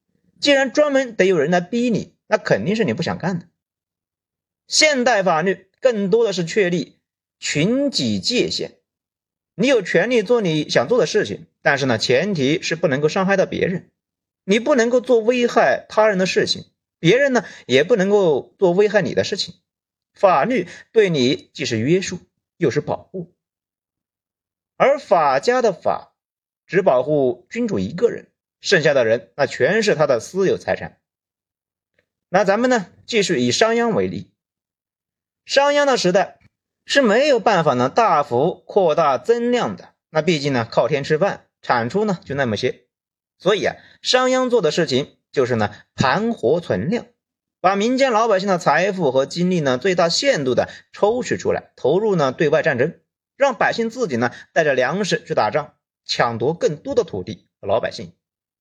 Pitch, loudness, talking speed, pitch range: 210 Hz, -19 LUFS, 240 characters per minute, 175-255 Hz